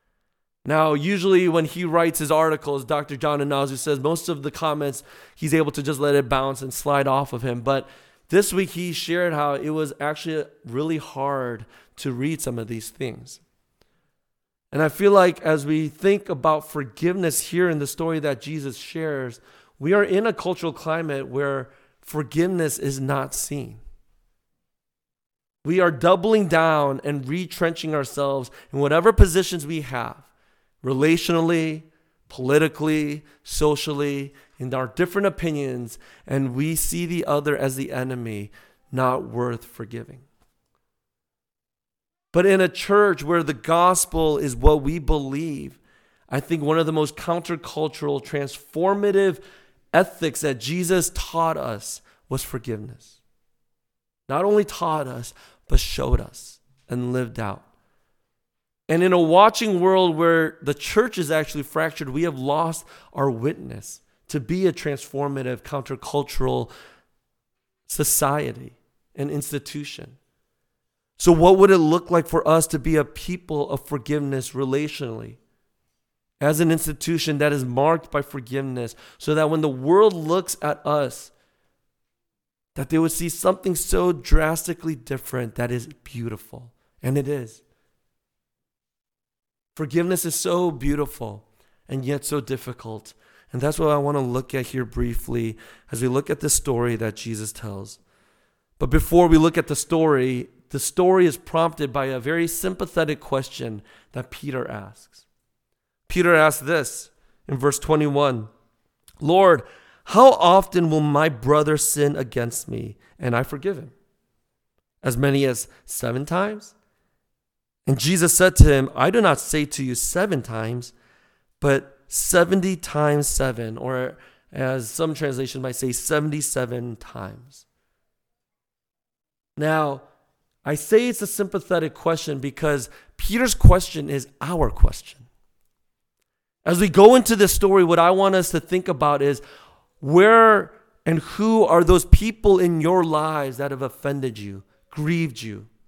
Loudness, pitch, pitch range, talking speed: -21 LUFS, 150 Hz, 135-170 Hz, 140 wpm